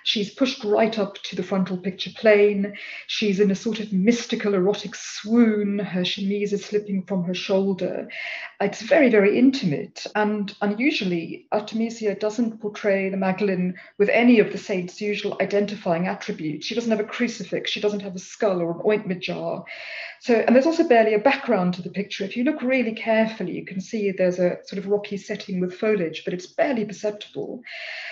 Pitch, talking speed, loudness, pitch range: 205 Hz, 185 wpm, -23 LUFS, 195-220 Hz